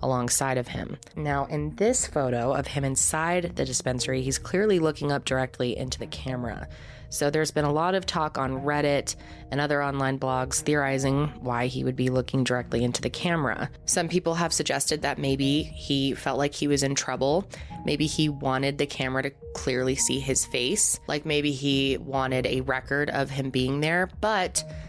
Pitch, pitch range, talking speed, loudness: 135 Hz, 130-150 Hz, 185 wpm, -26 LUFS